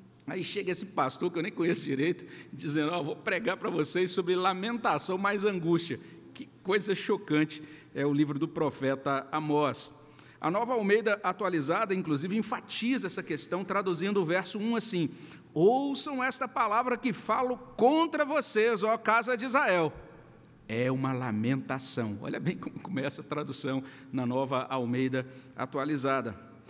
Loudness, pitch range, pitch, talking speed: -30 LUFS, 140-210 Hz, 175 Hz, 150 wpm